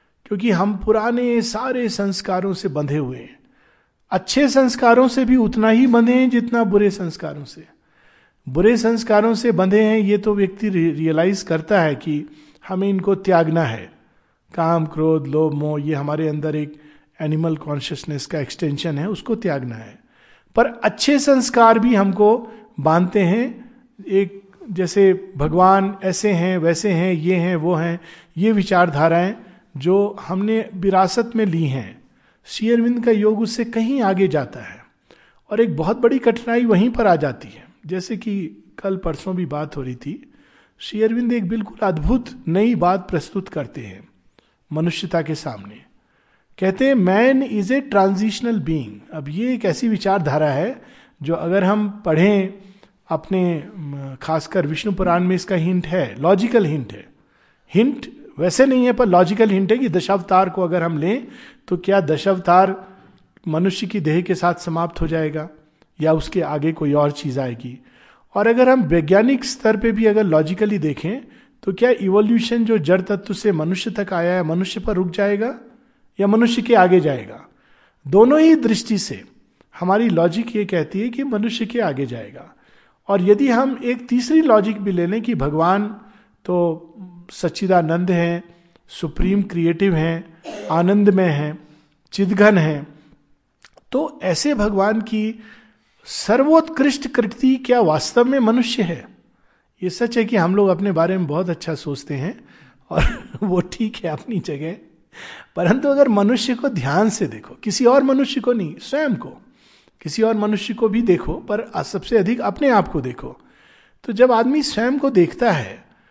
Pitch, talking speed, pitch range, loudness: 195 Hz, 160 wpm, 165-225 Hz, -18 LUFS